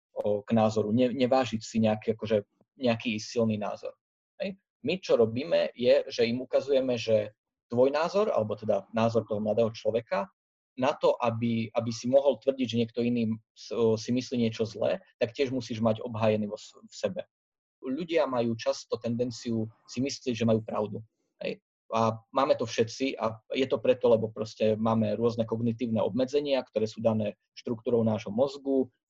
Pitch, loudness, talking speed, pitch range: 115 Hz, -29 LUFS, 160 wpm, 110-130 Hz